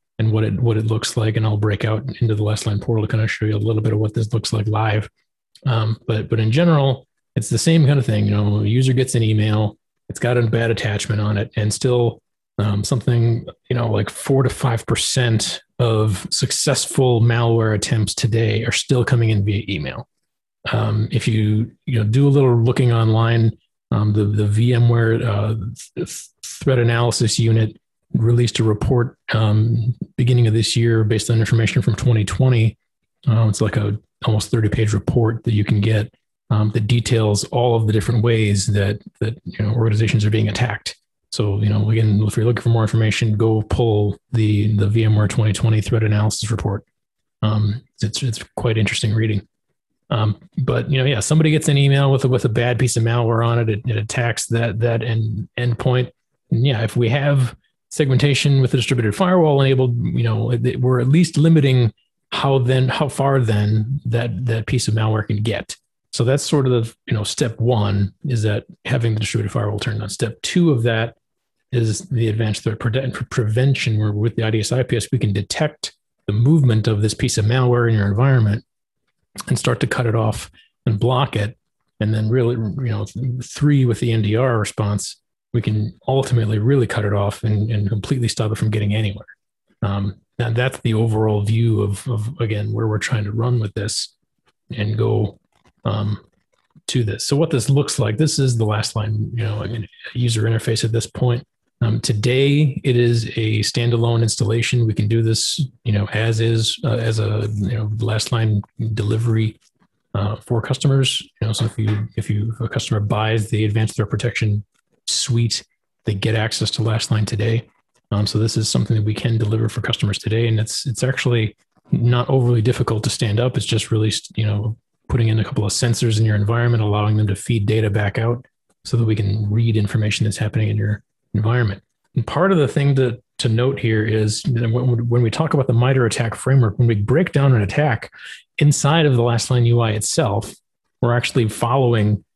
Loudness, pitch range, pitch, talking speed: -19 LUFS, 110-125 Hz, 115 Hz, 200 wpm